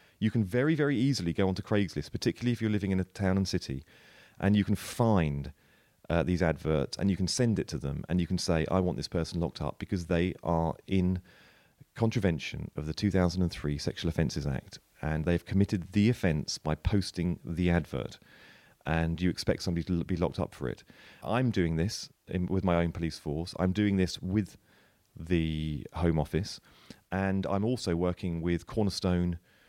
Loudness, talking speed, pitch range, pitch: -31 LUFS, 190 wpm, 80-100 Hz, 90 Hz